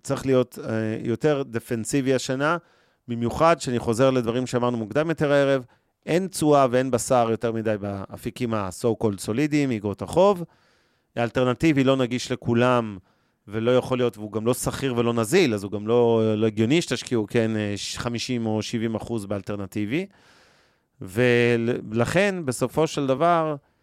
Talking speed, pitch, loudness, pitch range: 140 wpm, 120 Hz, -23 LUFS, 110-135 Hz